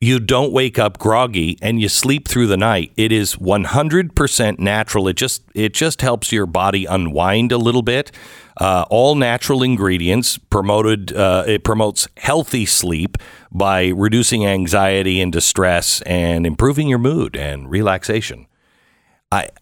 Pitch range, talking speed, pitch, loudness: 95-125 Hz, 145 wpm, 105 Hz, -16 LUFS